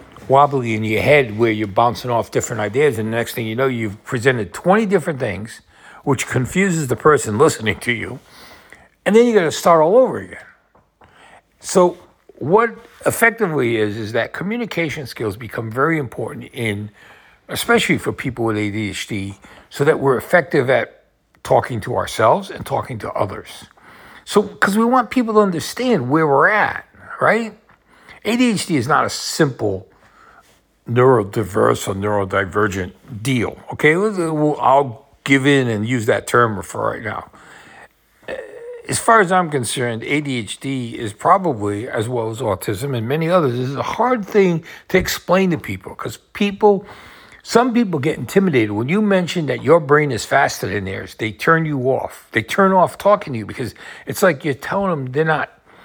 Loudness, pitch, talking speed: -18 LUFS, 140 Hz, 165 wpm